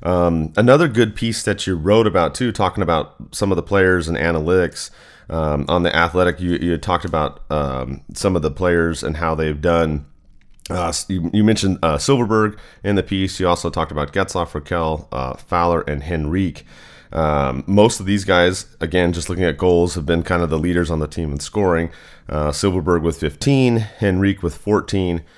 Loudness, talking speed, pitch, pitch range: -19 LUFS, 195 wpm, 85 Hz, 80-95 Hz